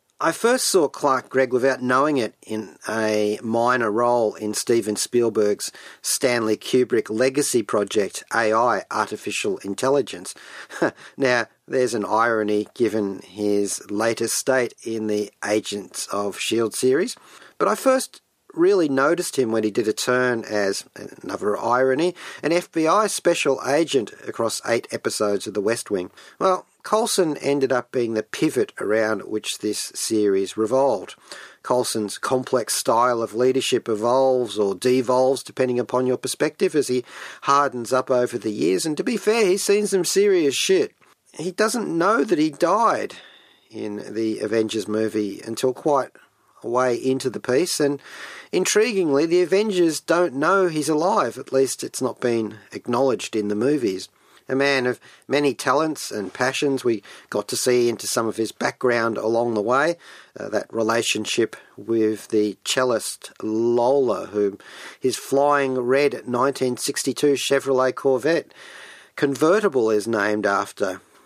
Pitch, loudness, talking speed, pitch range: 125 Hz, -22 LUFS, 145 wpm, 110-145 Hz